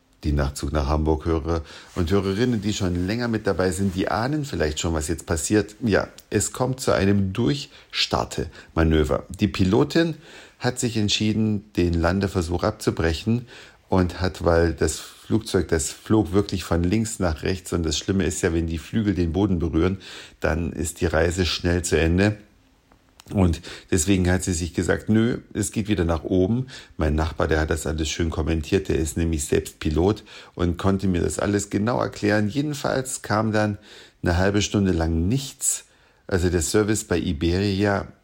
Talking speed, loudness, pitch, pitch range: 170 wpm, -23 LUFS, 95 Hz, 85-105 Hz